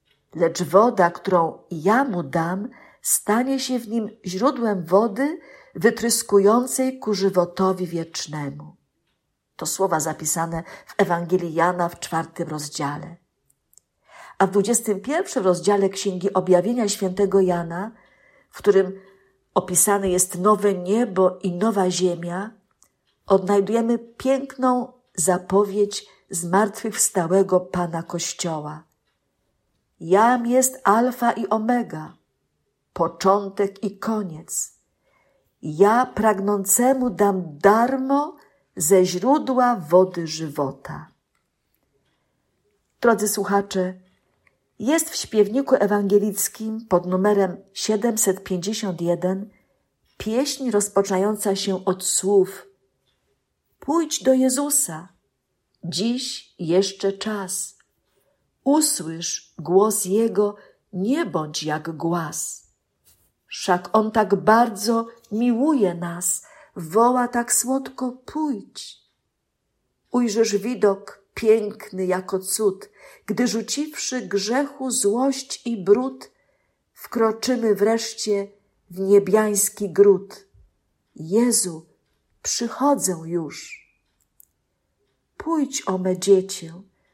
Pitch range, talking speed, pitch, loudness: 185-235 Hz, 85 wpm, 200 Hz, -21 LUFS